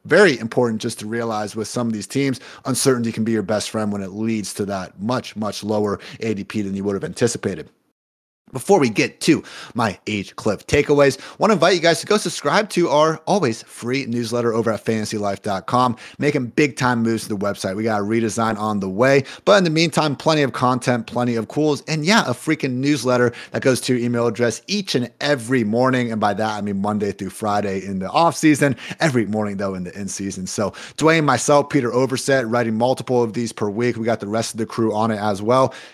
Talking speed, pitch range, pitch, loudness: 225 wpm, 105-140 Hz, 120 Hz, -20 LUFS